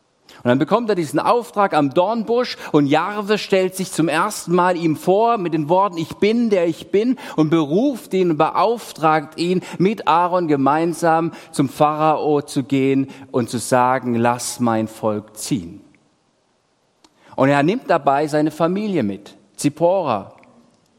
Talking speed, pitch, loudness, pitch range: 150 wpm, 160 Hz, -18 LUFS, 140-185 Hz